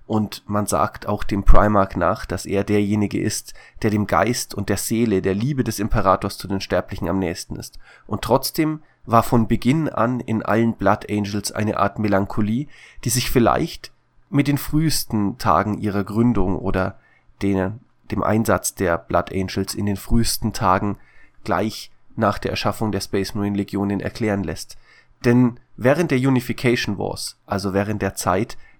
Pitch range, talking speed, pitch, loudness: 95-115 Hz, 165 wpm, 105 Hz, -21 LUFS